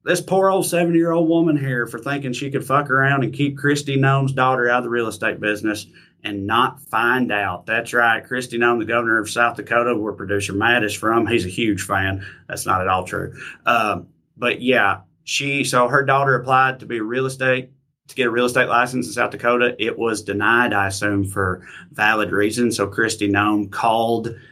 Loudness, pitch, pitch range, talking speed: -19 LUFS, 120 Hz, 105-135 Hz, 205 wpm